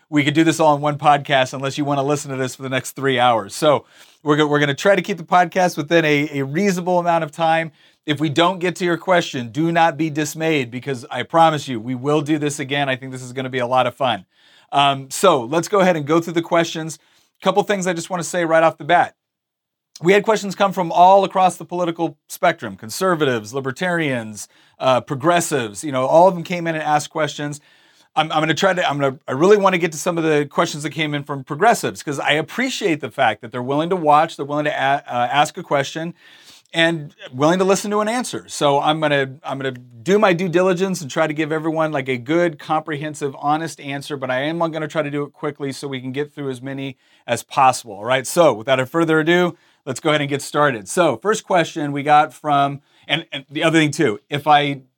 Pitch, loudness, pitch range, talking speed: 155 Hz, -19 LUFS, 140-170 Hz, 250 wpm